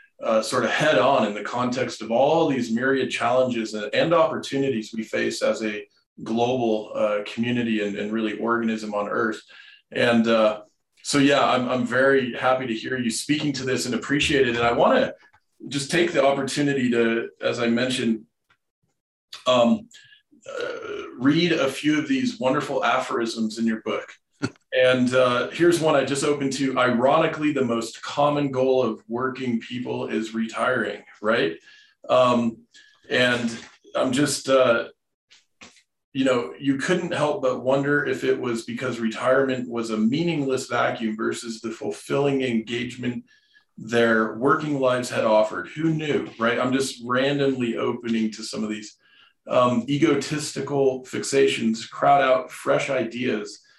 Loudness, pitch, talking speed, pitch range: -23 LUFS, 130 Hz, 150 wpm, 115-145 Hz